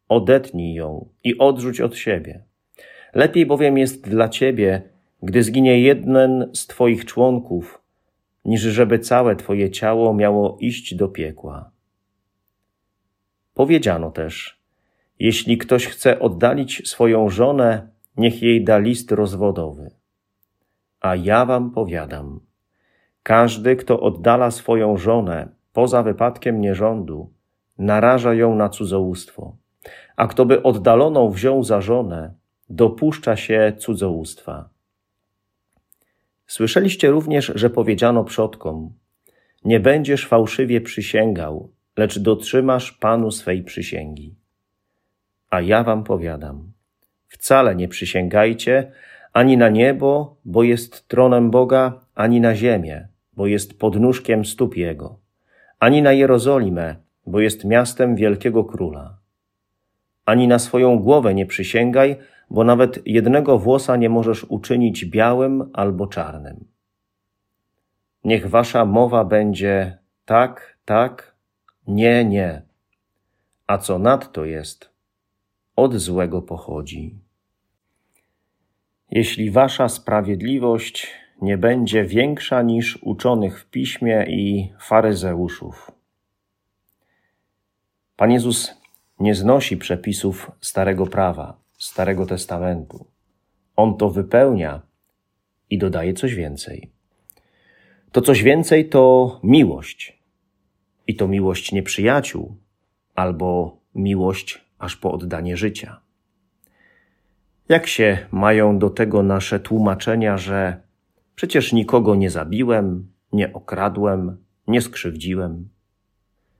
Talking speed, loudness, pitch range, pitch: 100 wpm, -18 LUFS, 95-120 Hz, 105 Hz